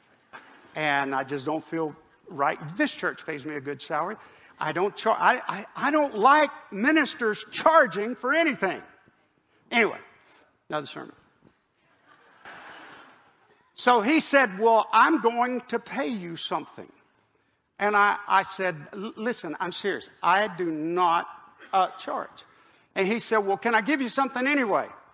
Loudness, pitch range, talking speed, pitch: -25 LUFS, 170-260 Hz, 145 wpm, 215 Hz